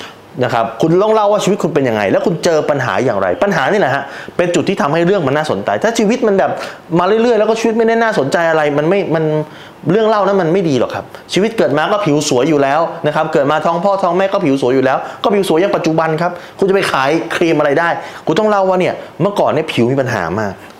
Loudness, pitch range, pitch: -14 LUFS, 150-200 Hz, 170 Hz